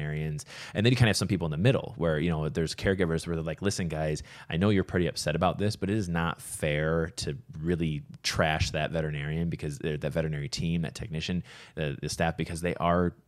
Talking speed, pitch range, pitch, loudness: 230 wpm, 80-95 Hz, 85 Hz, -29 LUFS